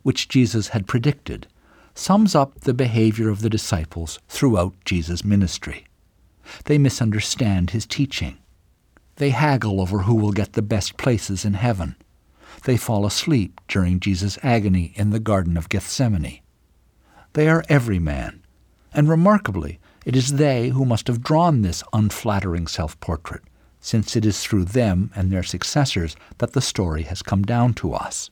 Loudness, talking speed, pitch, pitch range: -21 LUFS, 155 wpm, 105 Hz, 90-125 Hz